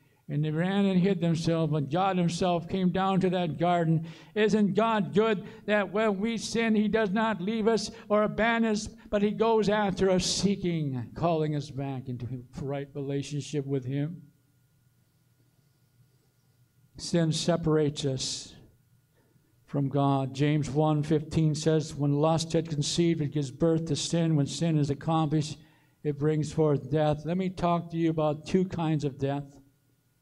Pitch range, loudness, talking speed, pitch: 140-185 Hz, -28 LUFS, 155 wpm, 155 Hz